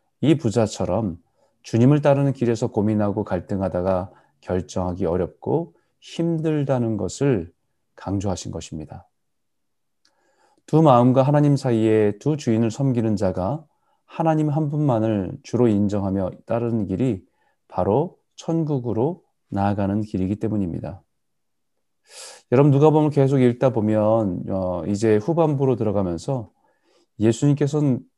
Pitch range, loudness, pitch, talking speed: 100-140 Hz, -21 LUFS, 115 Hz, 275 characters per minute